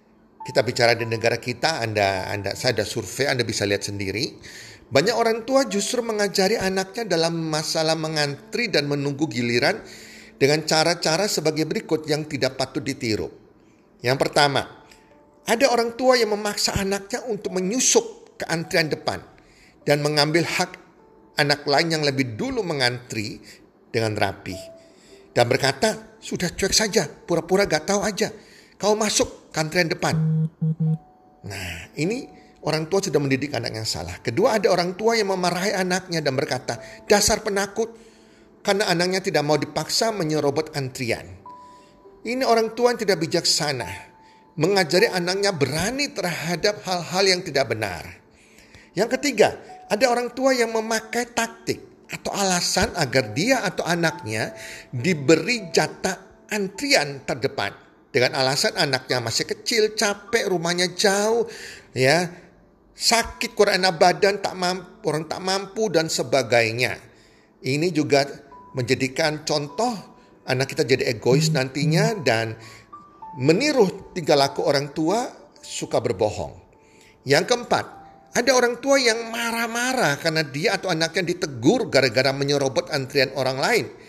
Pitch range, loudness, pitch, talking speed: 135-210 Hz, -22 LUFS, 165 Hz, 130 wpm